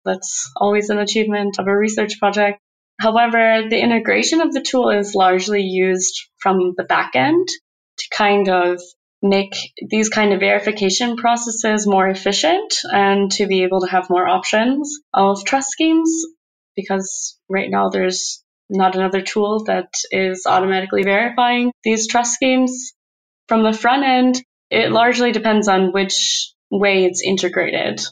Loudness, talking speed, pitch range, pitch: -17 LUFS, 145 wpm, 190-240 Hz, 205 Hz